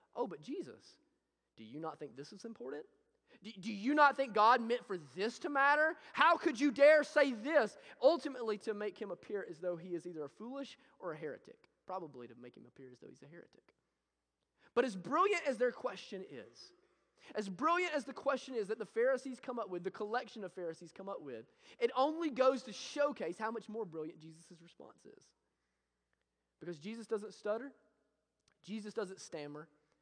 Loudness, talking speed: -36 LUFS, 195 wpm